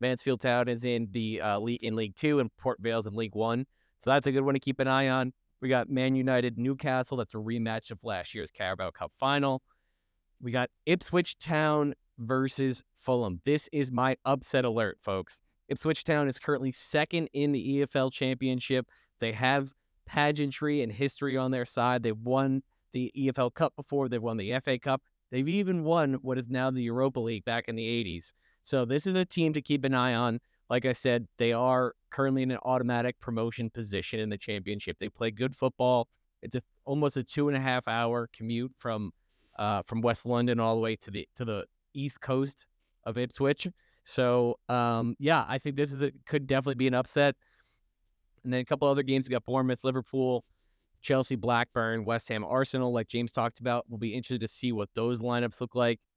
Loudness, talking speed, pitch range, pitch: -30 LUFS, 200 wpm, 115-135 Hz, 125 Hz